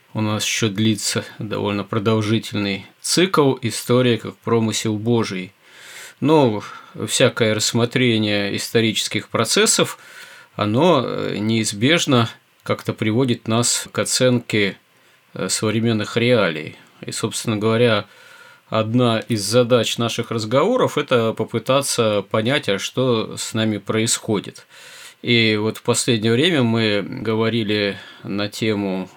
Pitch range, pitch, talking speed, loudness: 105-120 Hz, 110 Hz, 105 wpm, -19 LUFS